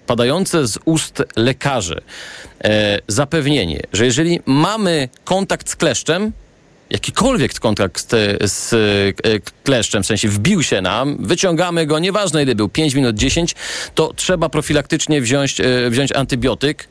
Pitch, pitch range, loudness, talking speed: 140 Hz, 115-165 Hz, -16 LUFS, 130 wpm